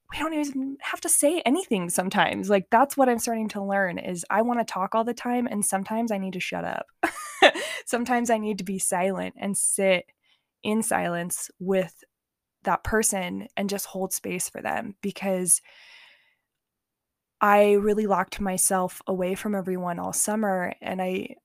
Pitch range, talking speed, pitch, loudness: 185-230 Hz, 170 wpm, 200 Hz, -25 LUFS